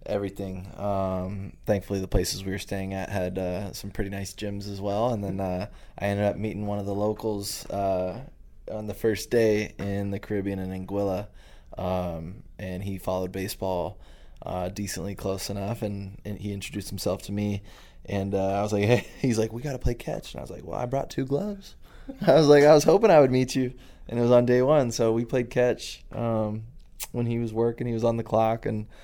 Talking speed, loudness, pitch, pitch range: 220 wpm, -26 LUFS, 100 Hz, 95-115 Hz